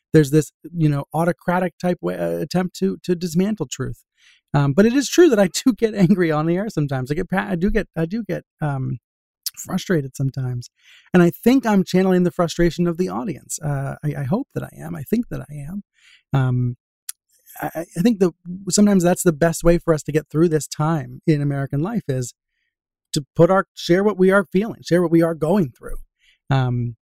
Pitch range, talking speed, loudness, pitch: 145-185 Hz, 210 wpm, -20 LUFS, 170 Hz